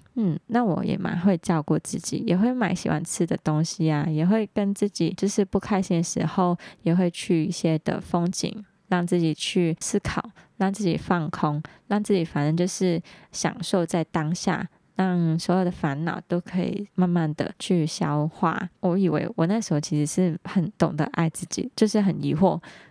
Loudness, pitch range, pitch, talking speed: -25 LUFS, 165-195 Hz, 180 Hz, 260 characters per minute